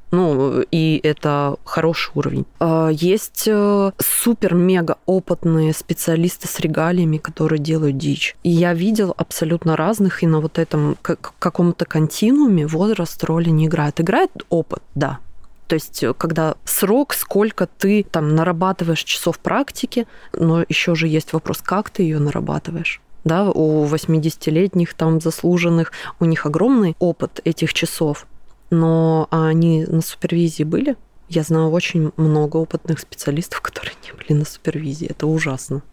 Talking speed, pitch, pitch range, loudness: 135 wpm, 165 Hz, 155-180 Hz, -18 LUFS